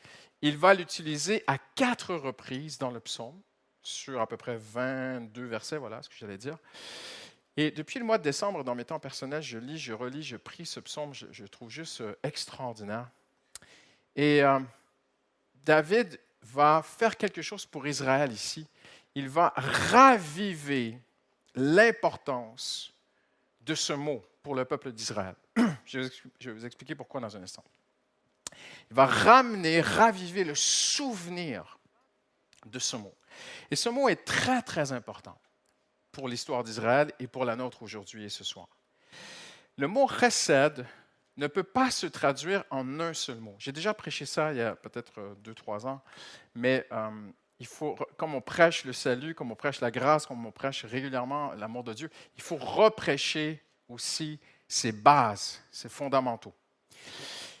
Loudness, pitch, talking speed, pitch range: -29 LUFS, 140 Hz, 155 wpm, 120-160 Hz